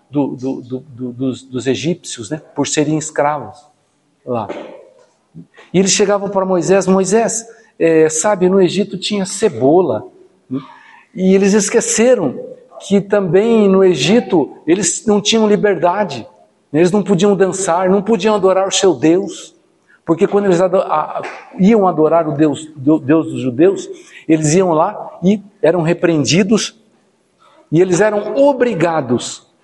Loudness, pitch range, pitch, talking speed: -14 LUFS, 155-210 Hz, 190 Hz, 145 wpm